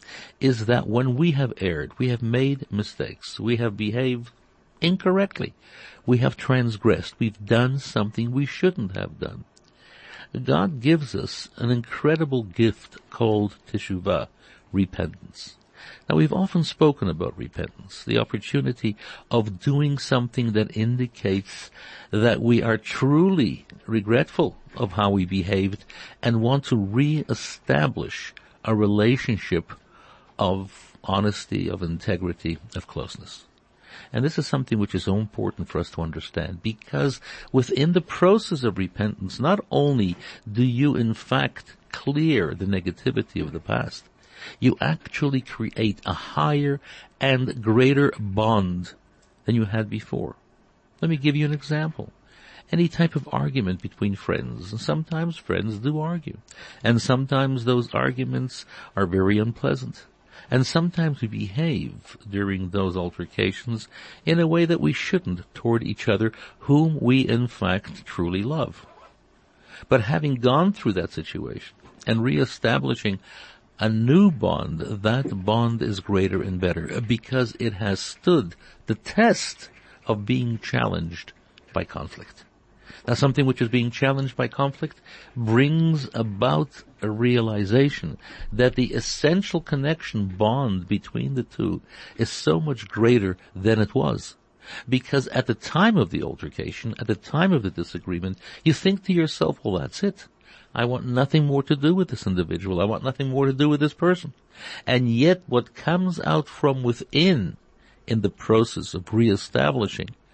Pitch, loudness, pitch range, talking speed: 120 Hz, -24 LUFS, 100-140 Hz, 140 wpm